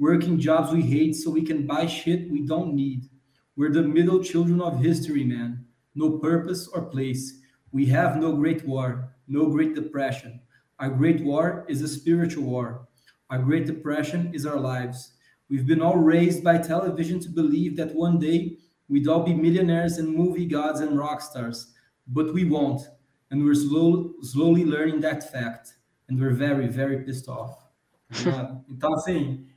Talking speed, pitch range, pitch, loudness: 170 wpm, 135-165 Hz, 150 Hz, -24 LUFS